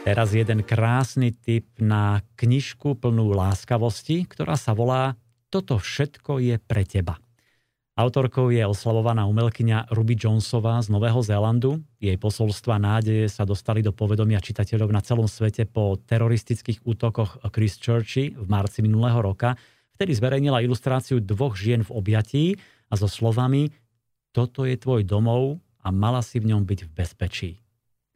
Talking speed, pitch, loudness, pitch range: 145 wpm, 115 Hz, -23 LUFS, 110-125 Hz